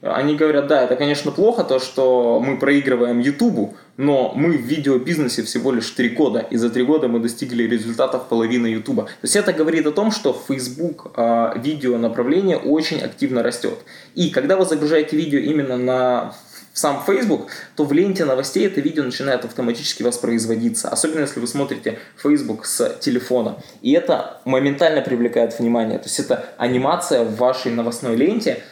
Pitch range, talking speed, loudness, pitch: 120-155 Hz, 165 wpm, -19 LUFS, 130 Hz